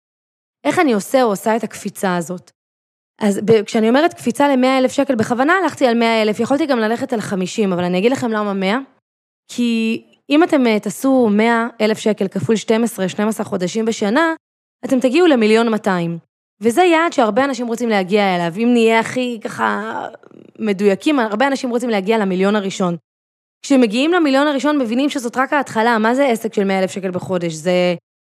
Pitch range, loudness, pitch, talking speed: 200-260 Hz, -16 LUFS, 225 Hz, 165 wpm